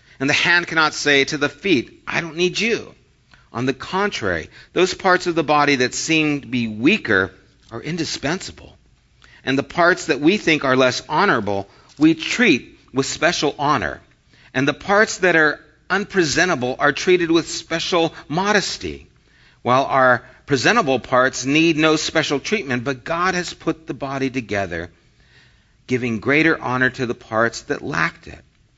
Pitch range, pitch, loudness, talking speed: 130-170 Hz, 150 Hz, -19 LUFS, 160 wpm